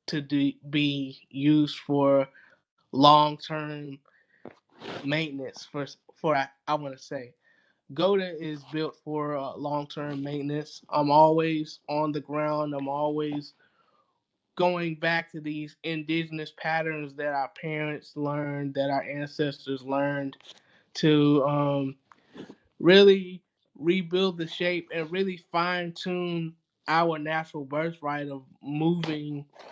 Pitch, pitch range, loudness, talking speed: 150 Hz, 145-160 Hz, -27 LUFS, 115 wpm